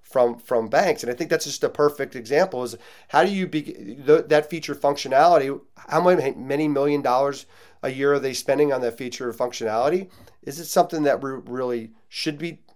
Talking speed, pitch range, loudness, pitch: 200 wpm, 125-150 Hz, -22 LUFS, 140 Hz